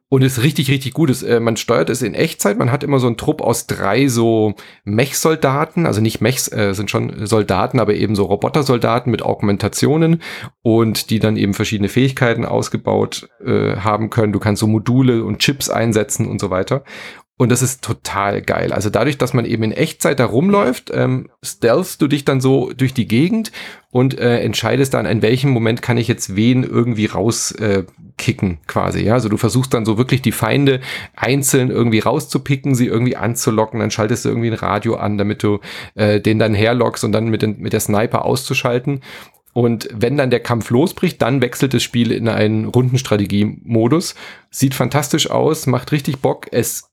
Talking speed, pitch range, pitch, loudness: 195 wpm, 110-135 Hz, 120 Hz, -16 LUFS